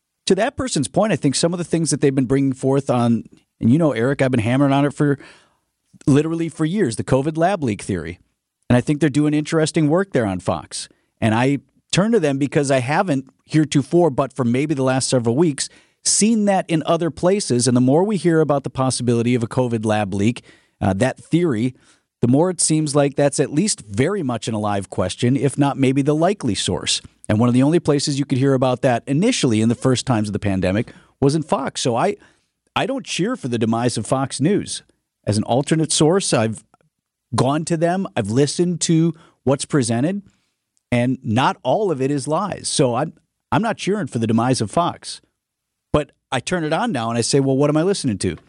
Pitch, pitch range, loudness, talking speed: 140 Hz, 120-155 Hz, -19 LUFS, 220 wpm